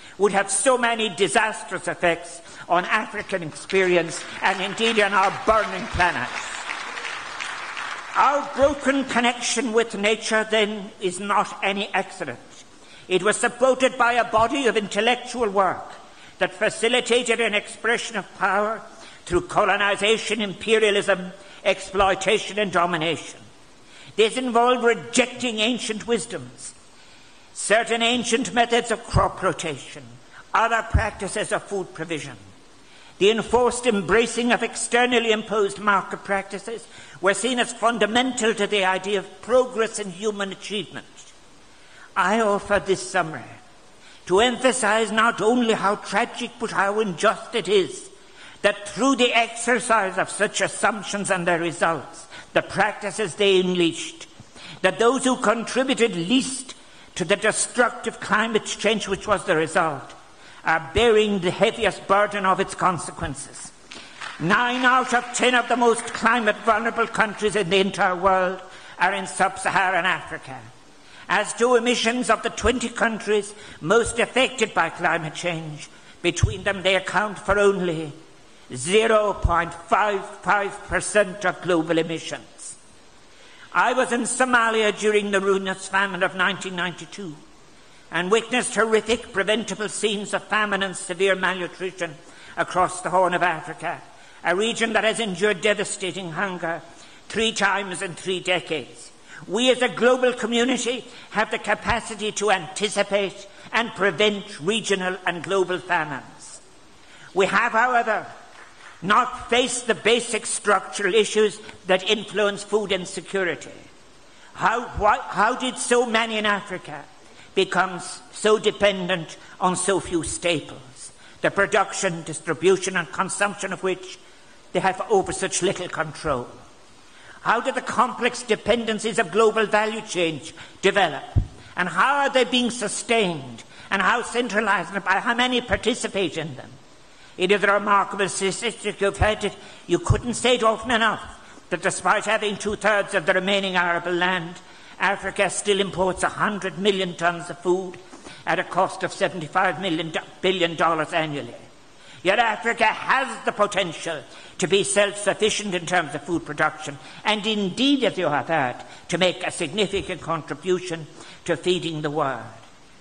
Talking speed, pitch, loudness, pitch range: 130 wpm, 200 Hz, -22 LUFS, 180-225 Hz